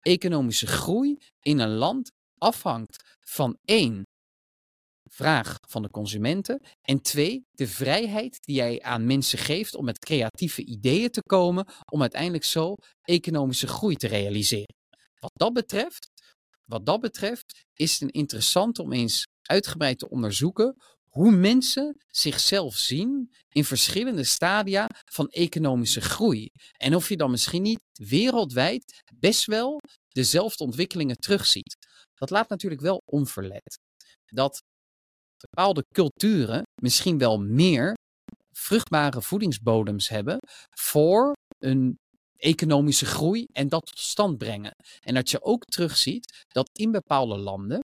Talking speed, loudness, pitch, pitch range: 130 wpm, -25 LUFS, 155 Hz, 130-210 Hz